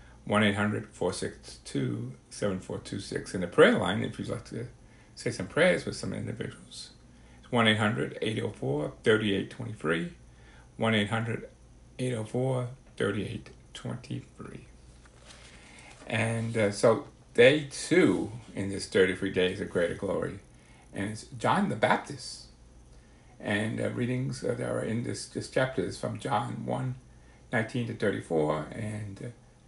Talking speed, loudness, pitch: 105 wpm, -29 LUFS, 100 Hz